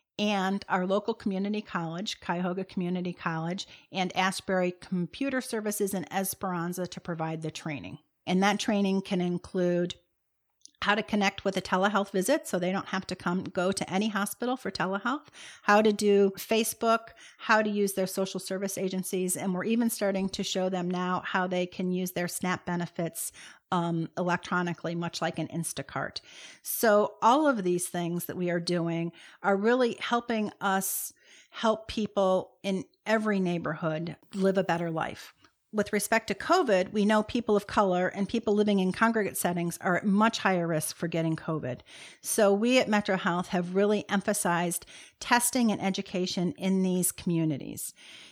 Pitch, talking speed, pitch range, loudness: 190 Hz, 165 wpm, 175-205 Hz, -29 LUFS